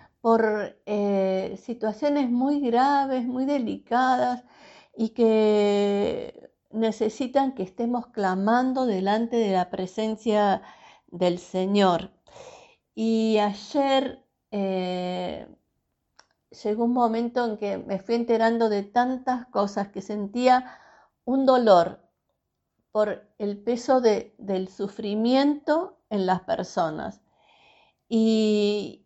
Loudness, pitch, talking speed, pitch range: -25 LUFS, 220 Hz, 95 wpm, 200-255 Hz